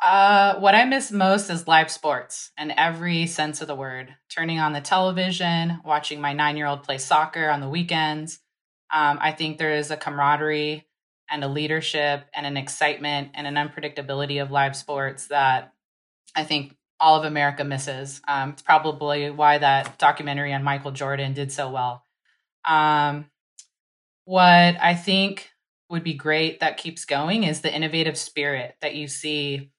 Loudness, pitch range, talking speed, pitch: -22 LUFS, 145-160 Hz, 165 wpm, 150 Hz